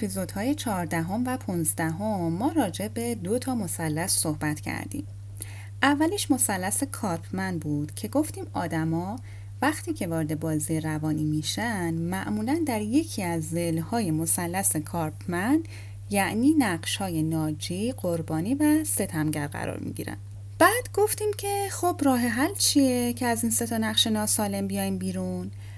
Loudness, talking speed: -26 LUFS, 135 wpm